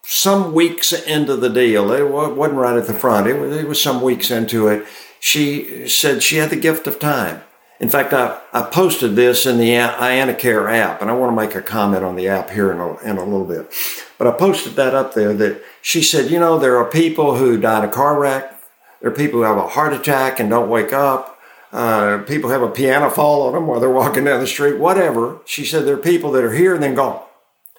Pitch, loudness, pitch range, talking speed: 135 Hz, -16 LUFS, 115-150 Hz, 230 wpm